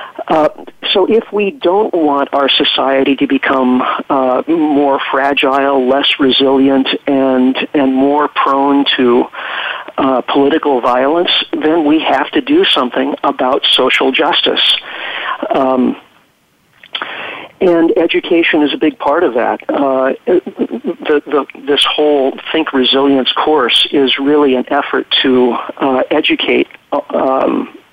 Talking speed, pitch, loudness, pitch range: 120 wpm, 140 Hz, -12 LUFS, 135-155 Hz